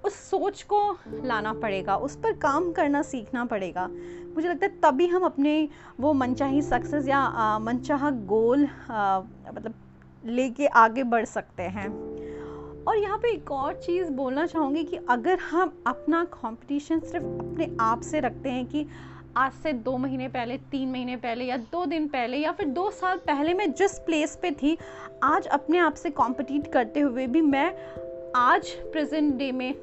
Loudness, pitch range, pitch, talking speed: -26 LUFS, 245-325 Hz, 285 Hz, 170 wpm